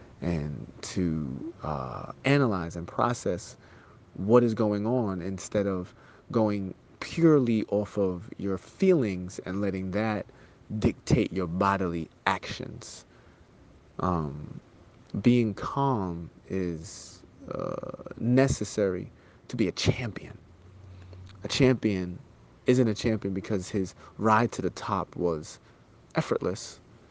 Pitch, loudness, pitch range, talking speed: 100 Hz, -28 LUFS, 90-120 Hz, 105 wpm